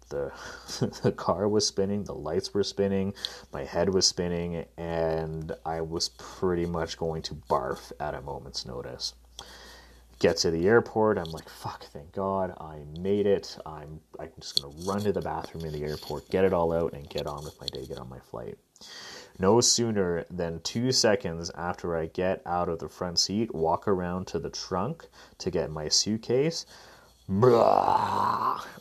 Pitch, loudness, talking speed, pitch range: 85 Hz, -28 LUFS, 175 wpm, 80-100 Hz